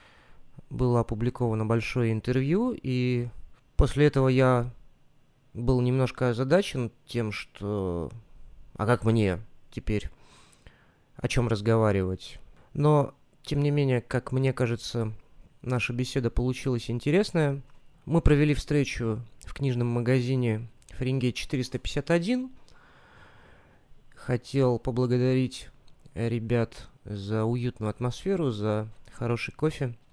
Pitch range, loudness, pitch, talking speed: 115-135 Hz, -27 LUFS, 125 Hz, 95 wpm